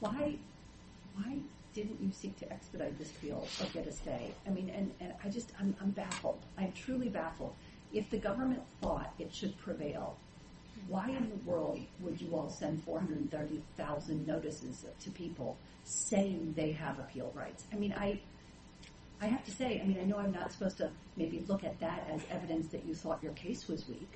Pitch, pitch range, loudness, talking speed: 190 Hz, 160-210 Hz, -40 LUFS, 190 wpm